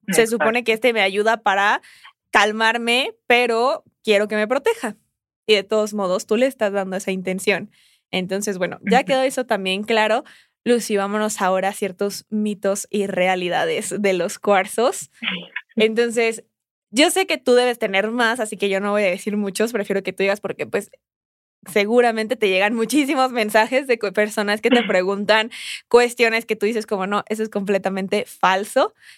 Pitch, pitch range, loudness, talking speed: 215 Hz, 200-235 Hz, -20 LUFS, 170 wpm